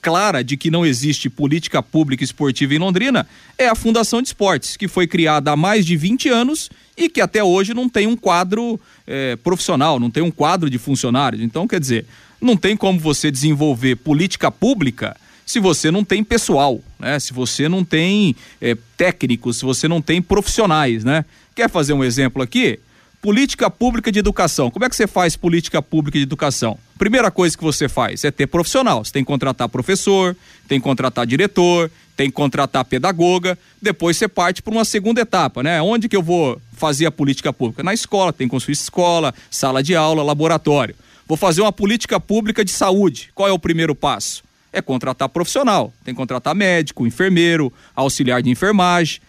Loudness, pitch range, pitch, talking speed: -17 LUFS, 135-195 Hz, 165 Hz, 190 wpm